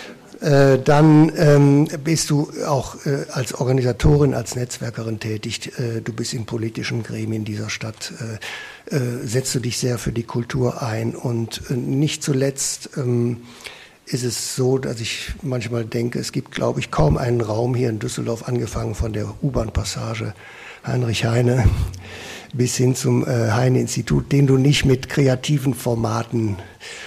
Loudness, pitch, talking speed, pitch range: -20 LUFS, 120 Hz, 155 wpm, 115-135 Hz